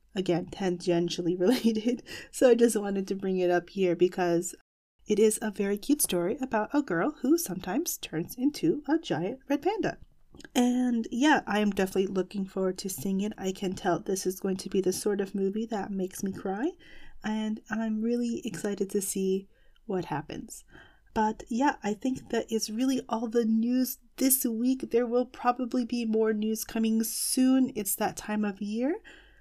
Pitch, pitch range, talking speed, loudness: 220 Hz, 195-250 Hz, 180 wpm, -29 LUFS